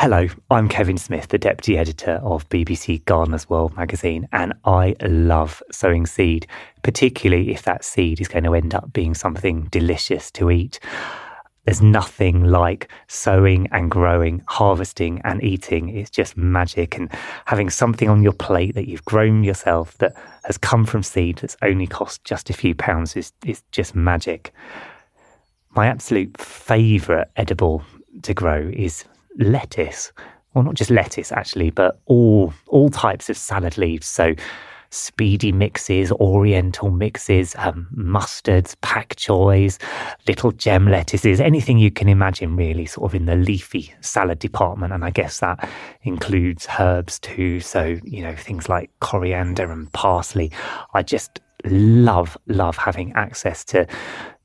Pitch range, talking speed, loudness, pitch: 85-105 Hz, 150 wpm, -19 LUFS, 95 Hz